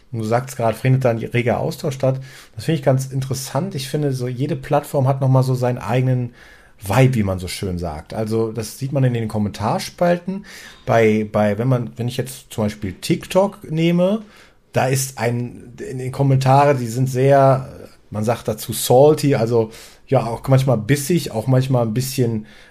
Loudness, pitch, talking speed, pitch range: -19 LUFS, 130 Hz, 190 wpm, 115-140 Hz